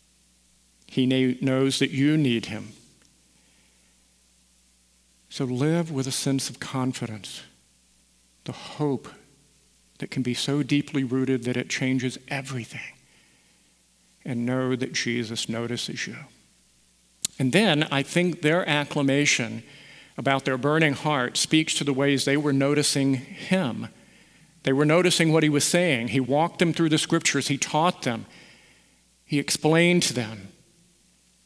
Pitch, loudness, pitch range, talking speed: 135 Hz, -24 LUFS, 115-150 Hz, 130 wpm